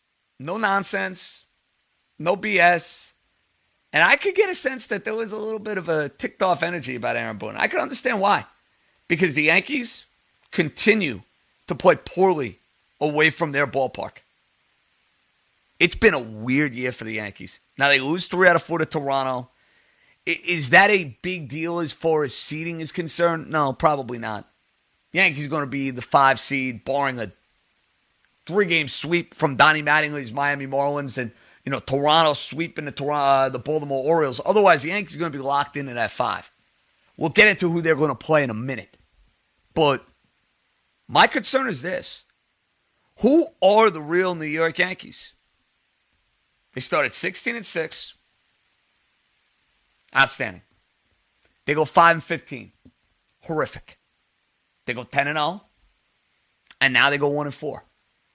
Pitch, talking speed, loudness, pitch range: 155 Hz, 160 wpm, -21 LUFS, 135-175 Hz